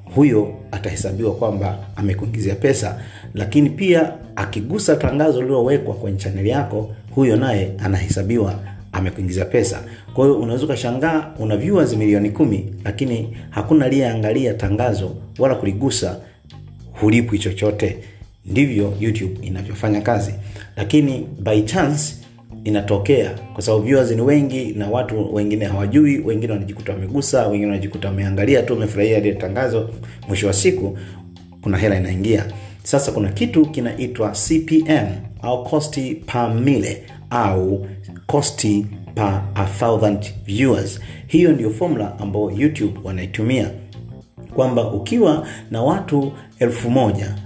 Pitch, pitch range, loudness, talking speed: 105 Hz, 100-125 Hz, -19 LUFS, 115 wpm